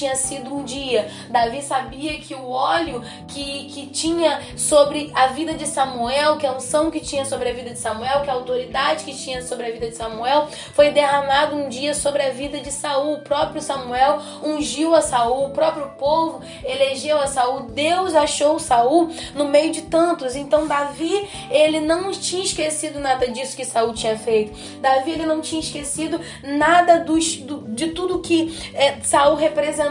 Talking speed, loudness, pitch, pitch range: 185 wpm, -20 LUFS, 285 Hz, 265-310 Hz